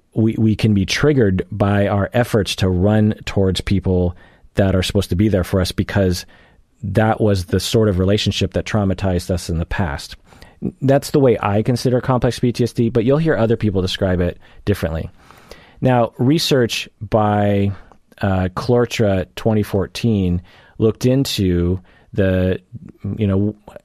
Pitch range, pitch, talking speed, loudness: 95-115 Hz, 100 Hz, 150 wpm, -18 LUFS